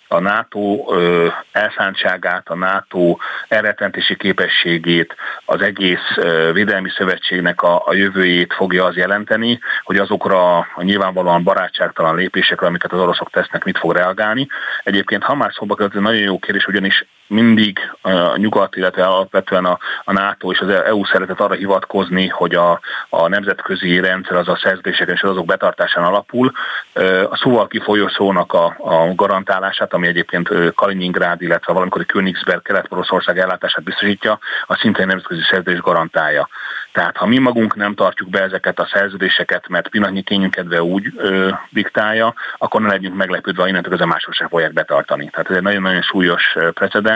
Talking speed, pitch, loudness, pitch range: 155 wpm, 95 Hz, -15 LUFS, 90-100 Hz